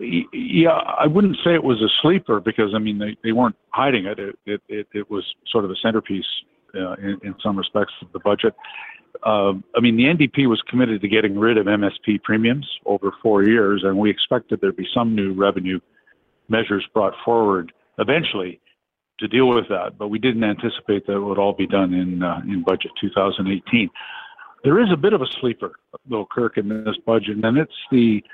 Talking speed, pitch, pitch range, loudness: 200 wpm, 105 Hz, 100-115 Hz, -20 LUFS